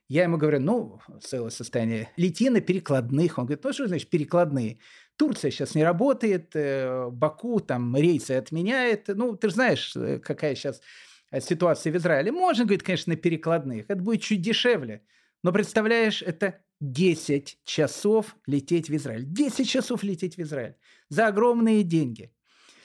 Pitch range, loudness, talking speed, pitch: 140-215 Hz, -25 LUFS, 150 wpm, 175 Hz